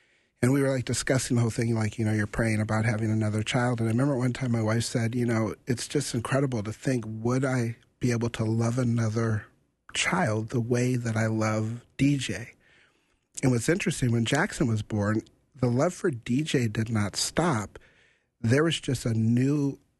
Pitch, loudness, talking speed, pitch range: 120 Hz, -27 LUFS, 195 wpm, 110-130 Hz